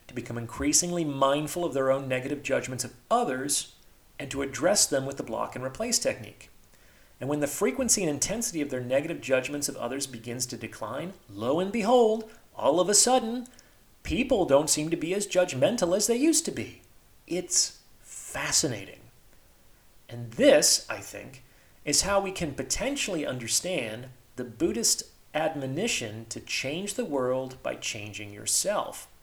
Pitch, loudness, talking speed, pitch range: 140 Hz, -27 LUFS, 160 wpm, 125-185 Hz